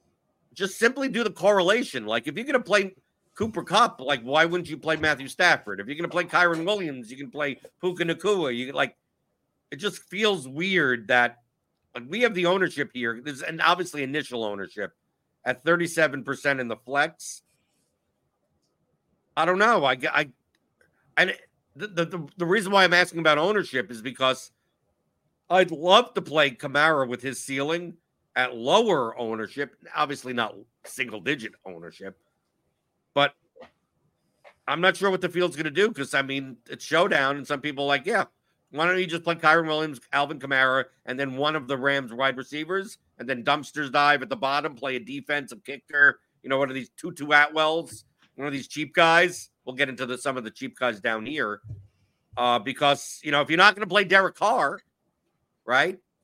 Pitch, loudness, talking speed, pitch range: 145 Hz, -24 LUFS, 180 wpm, 135-175 Hz